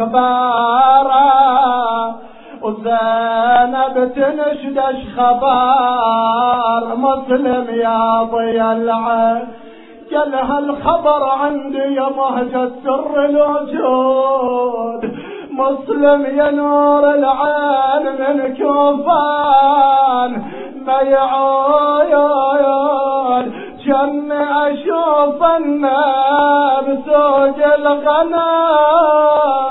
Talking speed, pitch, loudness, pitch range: 55 wpm, 270 Hz, -14 LUFS, 250-290 Hz